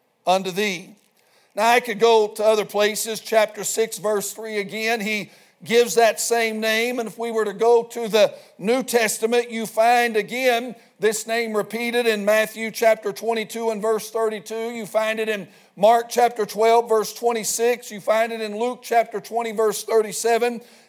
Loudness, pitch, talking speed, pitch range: -21 LUFS, 225 Hz, 170 wpm, 215-235 Hz